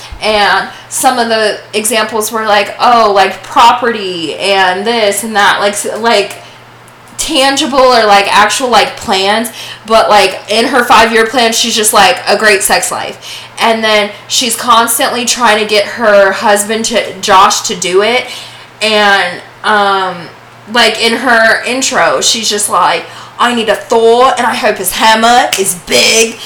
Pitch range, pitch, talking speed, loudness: 205-235 Hz, 220 Hz, 160 wpm, -8 LUFS